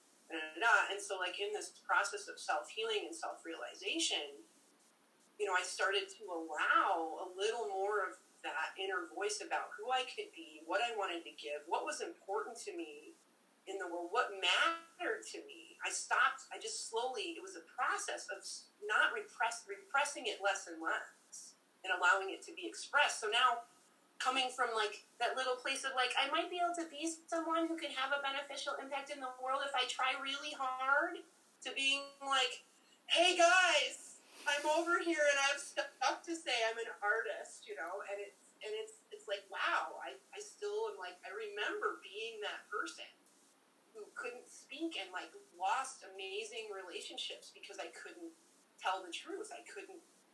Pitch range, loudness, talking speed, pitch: 255-390 Hz, -37 LUFS, 180 wpm, 320 Hz